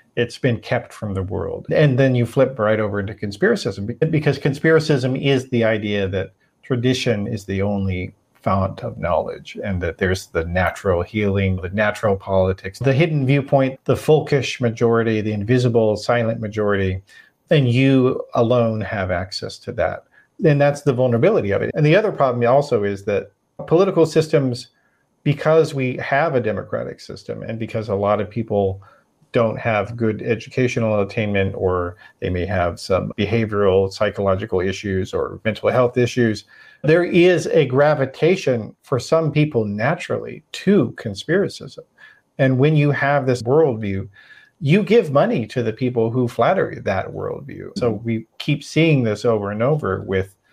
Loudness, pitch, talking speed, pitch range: -19 LUFS, 115 Hz, 160 wpm, 100-140 Hz